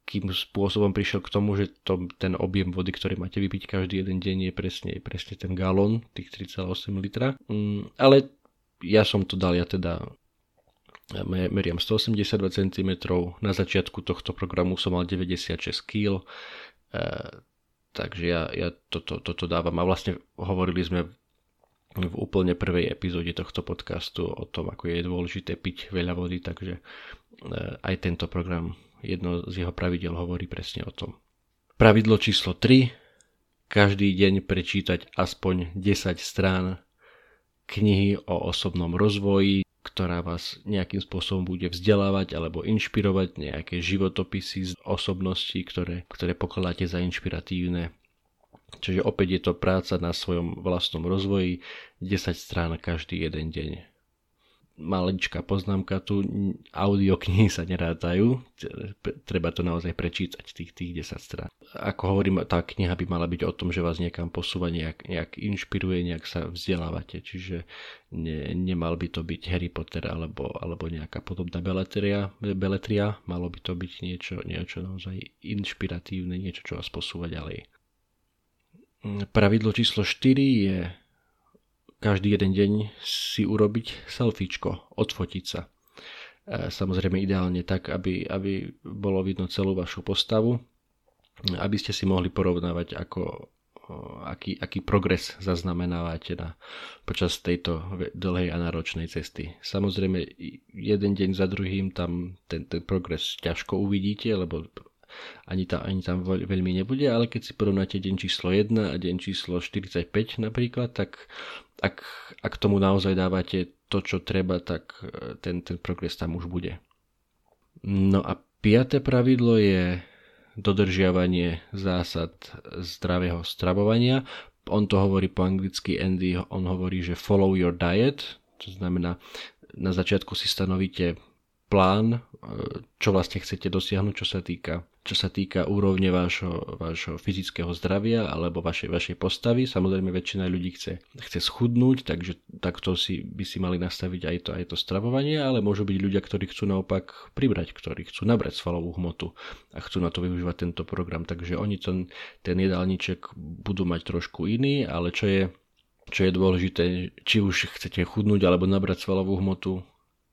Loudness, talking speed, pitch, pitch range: -27 LUFS, 140 wpm, 95 Hz, 90-100 Hz